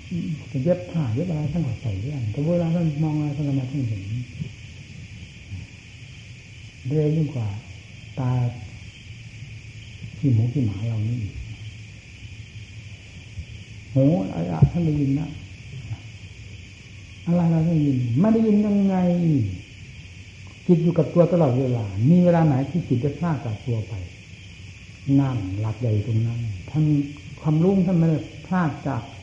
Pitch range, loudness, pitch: 105-150 Hz, -23 LUFS, 120 Hz